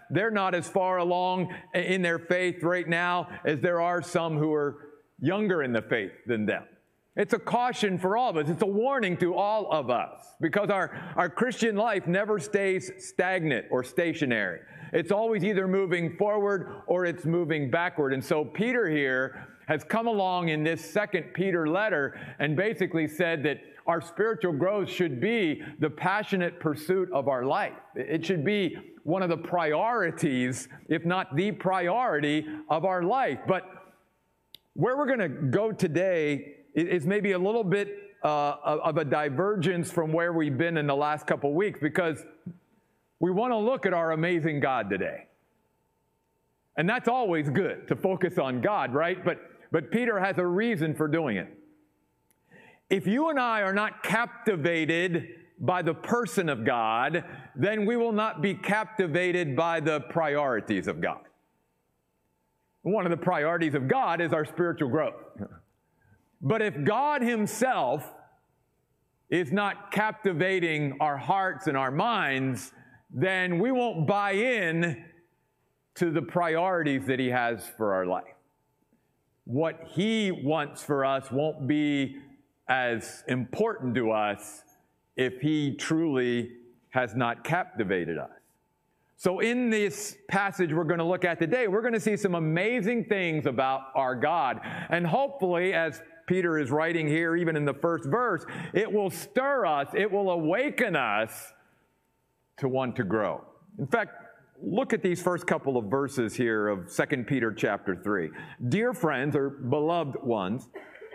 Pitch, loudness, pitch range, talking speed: 170 Hz, -28 LUFS, 150-195 Hz, 155 wpm